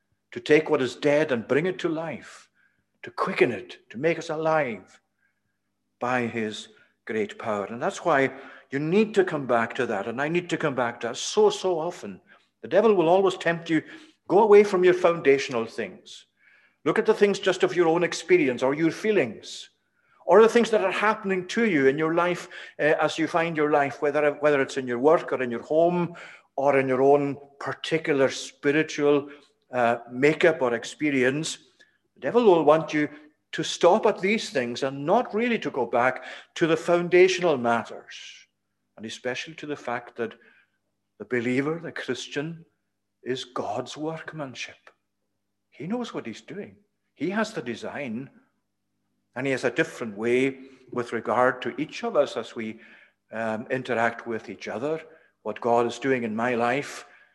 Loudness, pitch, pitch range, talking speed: -24 LUFS, 150 Hz, 125-170 Hz, 180 wpm